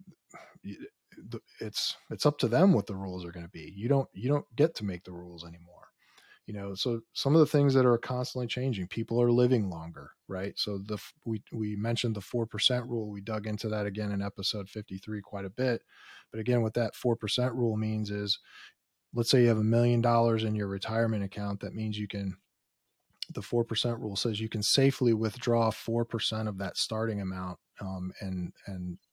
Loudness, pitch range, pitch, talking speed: -30 LUFS, 100-120 Hz, 110 Hz, 210 wpm